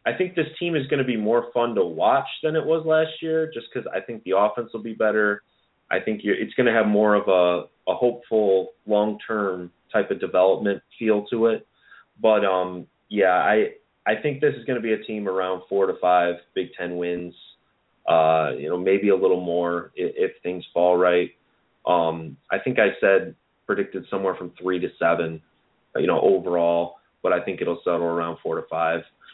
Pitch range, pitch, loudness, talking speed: 90-120 Hz, 100 Hz, -23 LUFS, 205 wpm